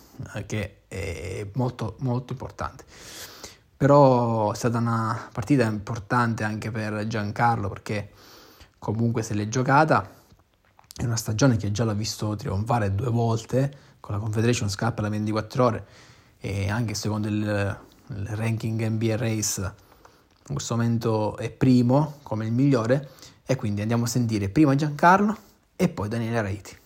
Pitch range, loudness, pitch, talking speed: 105-125 Hz, -25 LUFS, 115 Hz, 140 wpm